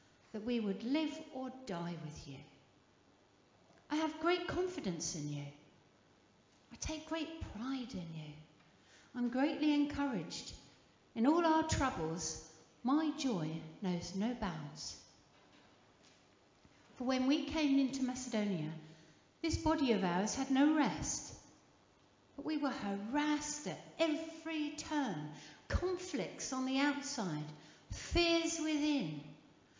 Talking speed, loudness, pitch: 115 wpm, -37 LUFS, 245 Hz